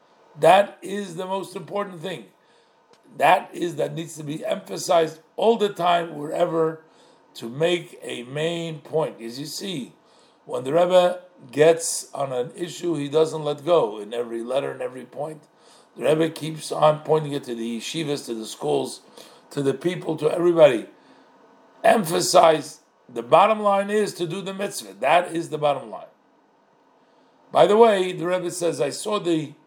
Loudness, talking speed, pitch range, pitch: -22 LUFS, 165 wpm, 150-185 Hz, 165 Hz